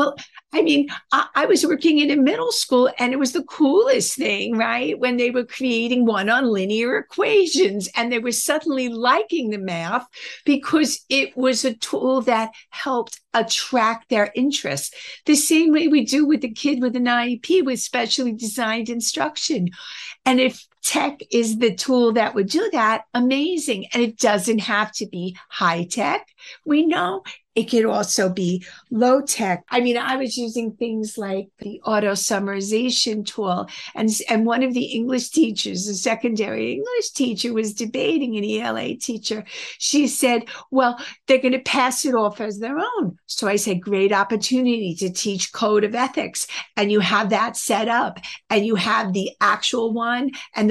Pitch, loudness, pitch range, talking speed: 240 Hz, -20 LUFS, 215-265 Hz, 175 wpm